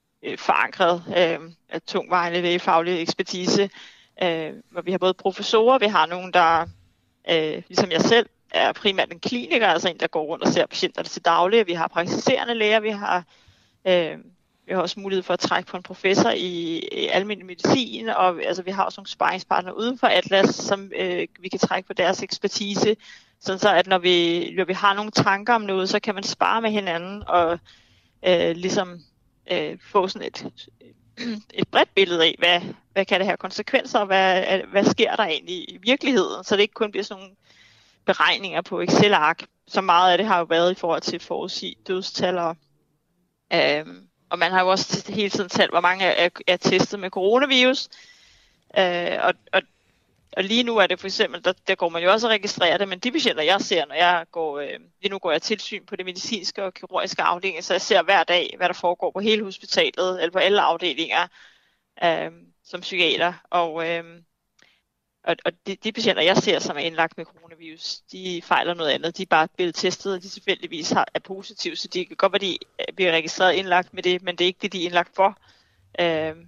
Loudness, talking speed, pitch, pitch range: -22 LUFS, 205 wpm, 185 Hz, 170-205 Hz